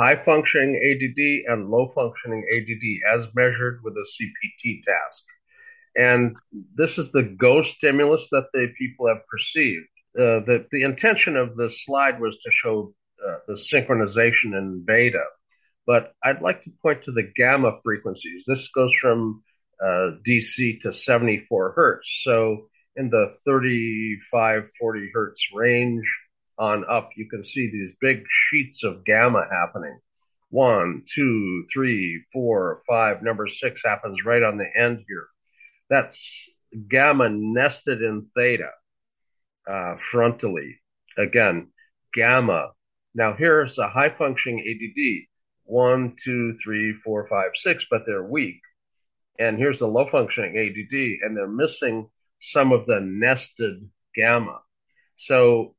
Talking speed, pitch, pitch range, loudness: 135 wpm, 120 Hz, 110-135 Hz, -21 LUFS